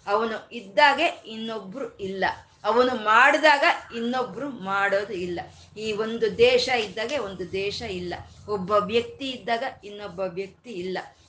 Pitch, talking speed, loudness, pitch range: 215 Hz, 115 wpm, -24 LUFS, 195-240 Hz